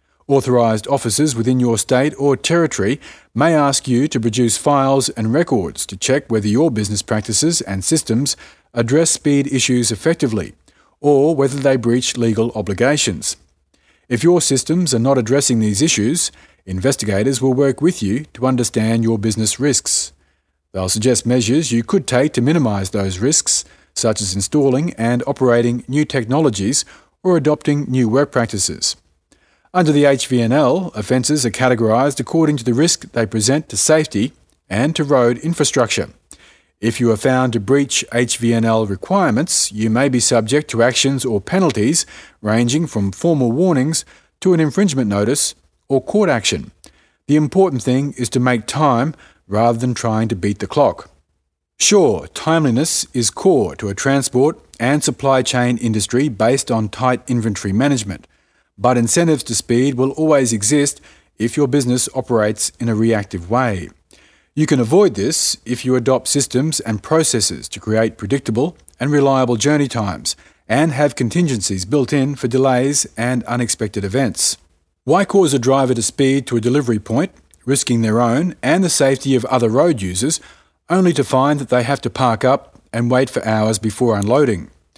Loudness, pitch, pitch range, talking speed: -16 LUFS, 125 Hz, 115-140 Hz, 160 wpm